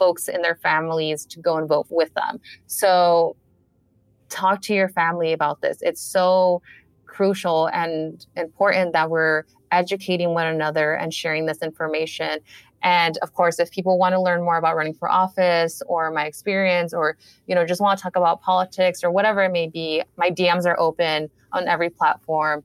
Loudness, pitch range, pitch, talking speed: -21 LUFS, 160-180 Hz, 170 Hz, 180 wpm